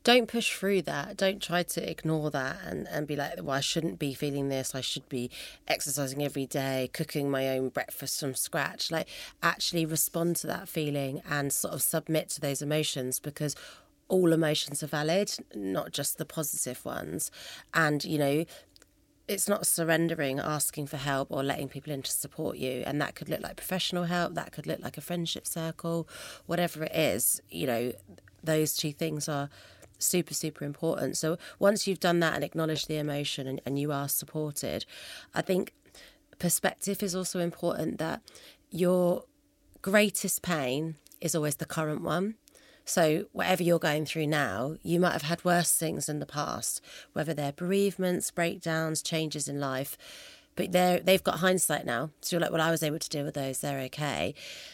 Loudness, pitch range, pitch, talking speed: -30 LUFS, 145-175 Hz, 160 Hz, 180 wpm